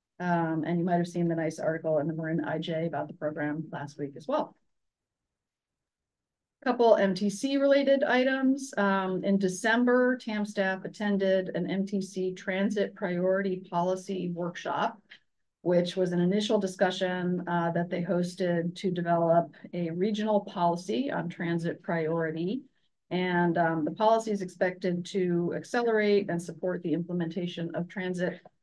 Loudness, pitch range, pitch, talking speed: -29 LUFS, 170-205 Hz, 180 Hz, 140 wpm